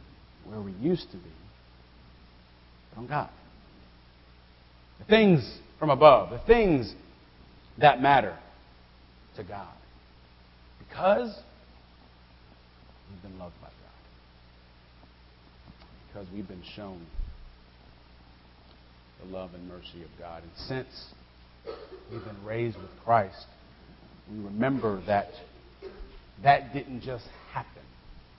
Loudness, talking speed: -25 LUFS, 100 wpm